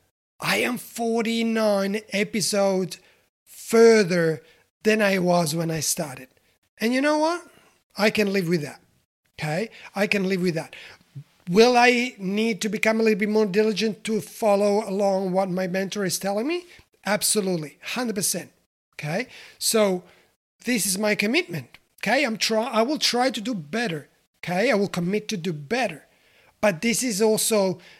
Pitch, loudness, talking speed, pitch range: 205 Hz, -23 LUFS, 155 wpm, 185-225 Hz